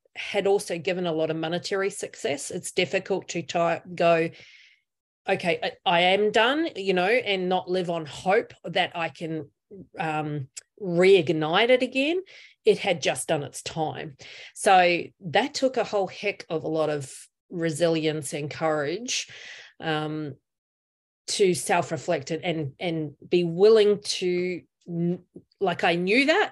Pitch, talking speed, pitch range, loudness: 175 Hz, 145 wpm, 160-195 Hz, -25 LUFS